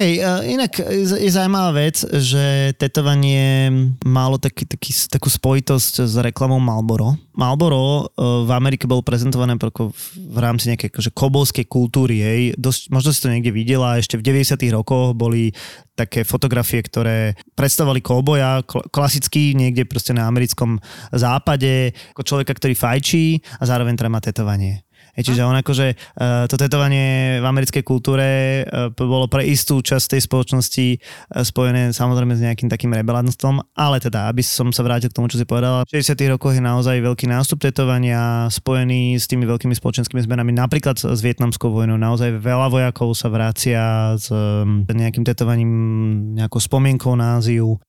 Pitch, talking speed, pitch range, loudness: 125 Hz, 150 wpm, 120-135 Hz, -17 LUFS